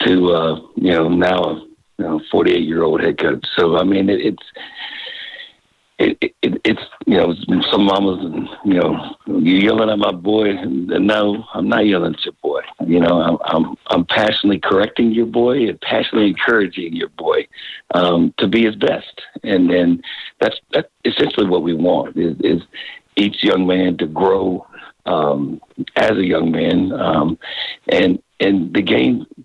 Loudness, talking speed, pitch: -16 LUFS, 175 wpm, 115 Hz